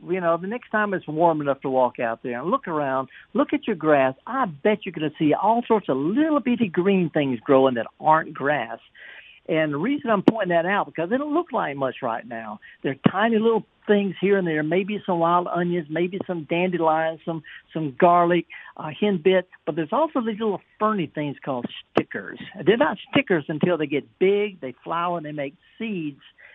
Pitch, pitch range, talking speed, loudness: 175 Hz, 150-210 Hz, 210 wpm, -23 LUFS